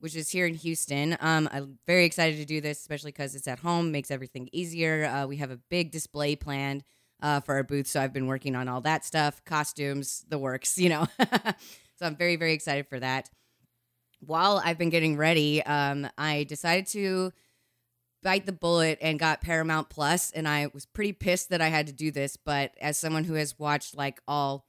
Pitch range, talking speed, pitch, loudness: 140-165 Hz, 210 wpm, 150 Hz, -28 LUFS